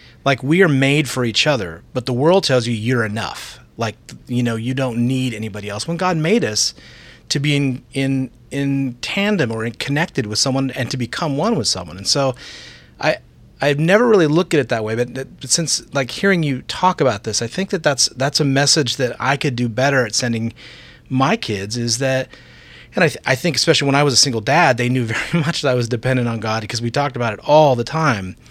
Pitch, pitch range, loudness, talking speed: 130 Hz, 120-145 Hz, -18 LUFS, 235 wpm